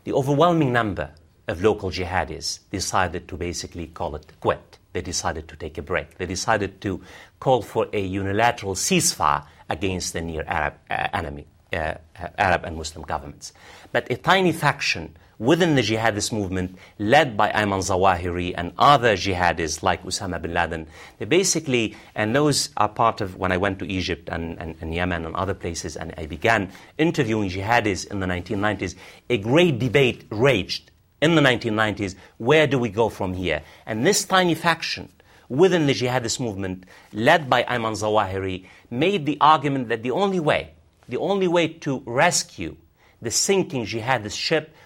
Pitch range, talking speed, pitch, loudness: 90-130 Hz, 165 wpm, 100 Hz, -22 LUFS